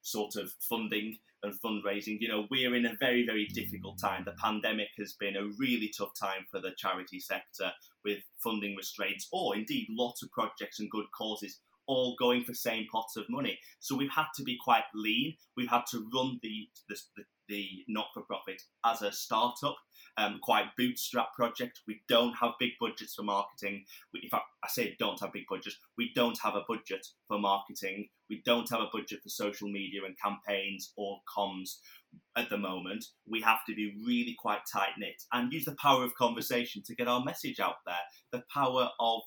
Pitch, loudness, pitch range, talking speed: 110 Hz, -34 LUFS, 100-125 Hz, 200 wpm